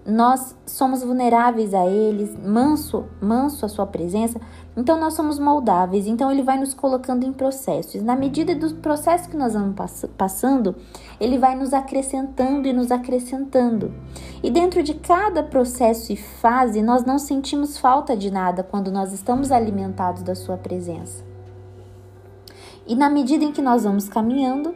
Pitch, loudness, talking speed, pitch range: 250 Hz, -21 LUFS, 160 wpm, 200-270 Hz